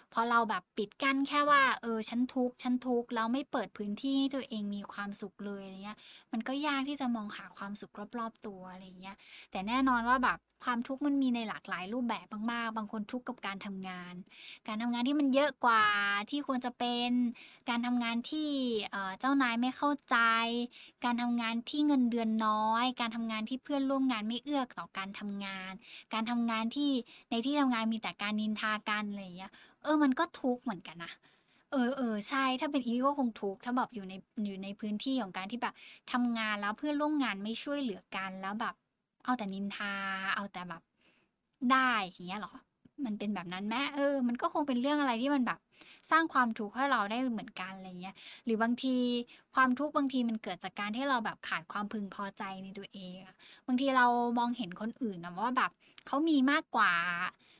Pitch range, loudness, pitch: 205-260 Hz, -33 LUFS, 235 Hz